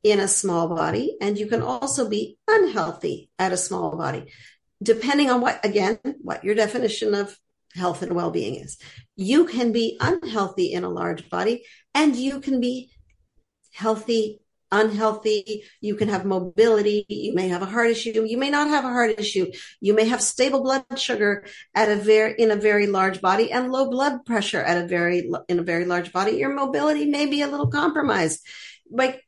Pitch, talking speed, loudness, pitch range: 220 Hz, 185 wpm, -22 LUFS, 195-260 Hz